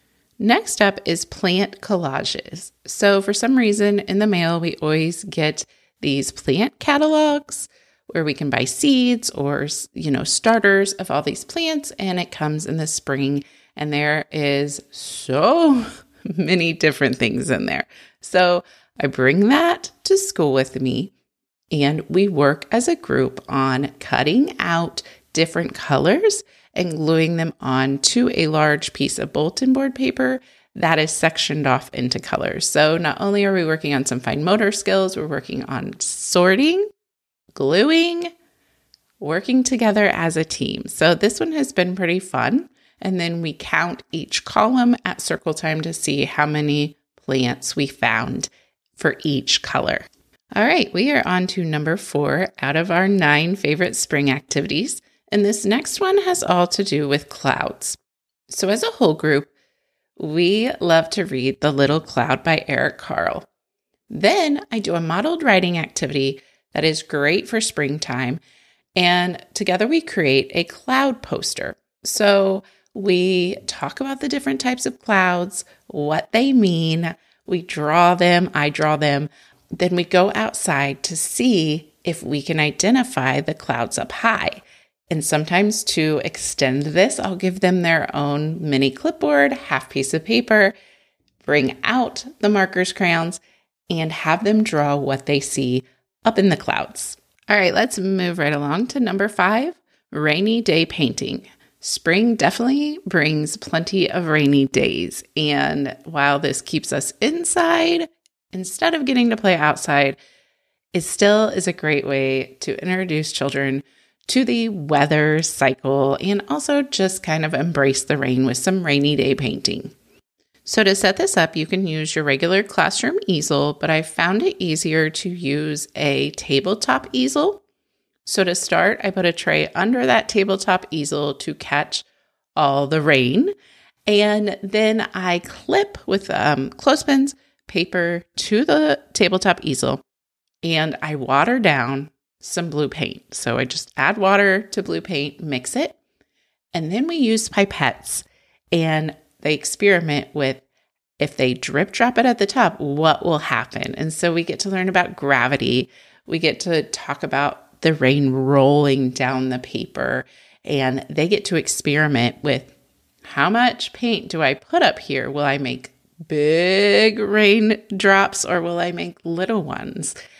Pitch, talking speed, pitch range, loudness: 170 Hz, 155 wpm, 145-205 Hz, -19 LUFS